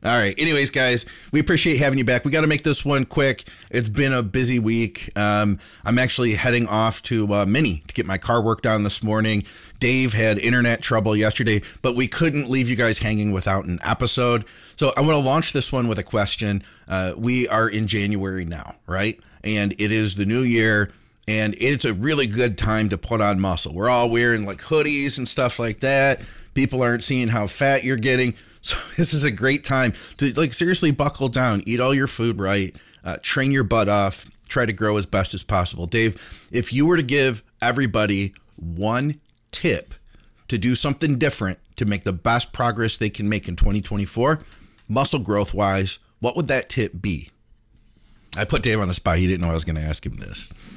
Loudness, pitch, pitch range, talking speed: -20 LUFS, 115 Hz, 105-130 Hz, 210 wpm